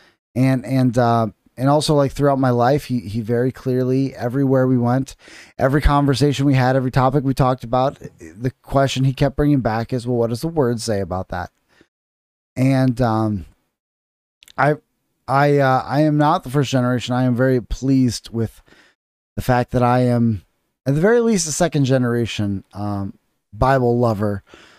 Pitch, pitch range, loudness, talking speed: 125 Hz, 115-135 Hz, -19 LUFS, 170 wpm